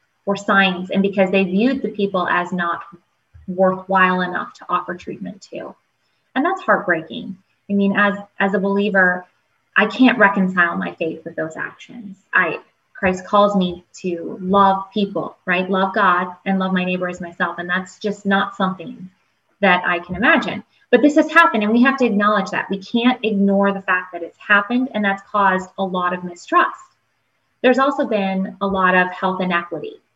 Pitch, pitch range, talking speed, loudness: 195 Hz, 180-210 Hz, 180 wpm, -18 LUFS